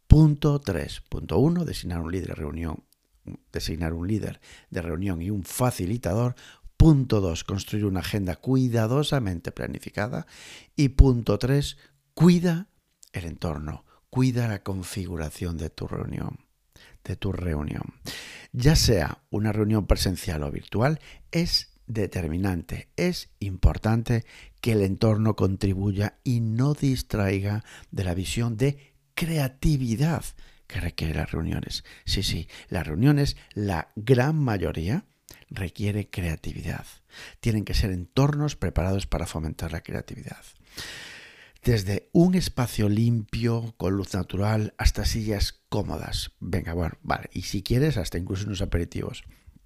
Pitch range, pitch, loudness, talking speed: 90-125 Hz, 105 Hz, -26 LUFS, 120 wpm